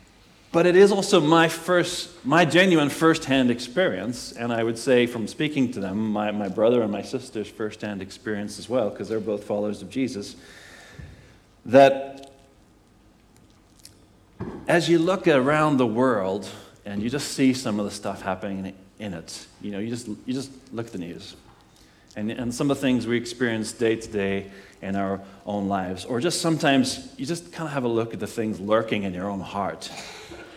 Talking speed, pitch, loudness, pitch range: 185 wpm, 115 Hz, -24 LUFS, 100-135 Hz